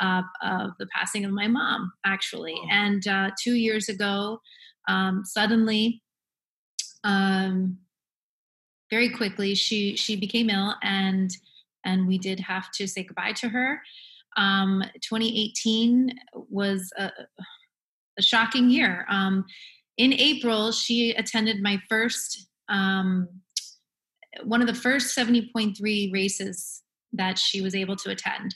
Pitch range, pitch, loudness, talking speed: 195-230 Hz, 205 Hz, -25 LUFS, 125 wpm